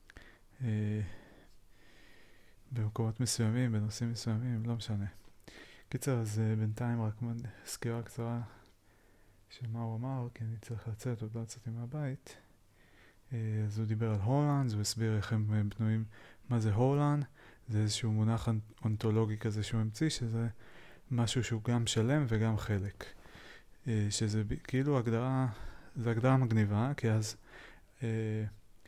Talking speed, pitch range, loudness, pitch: 140 wpm, 105-120 Hz, -35 LUFS, 110 Hz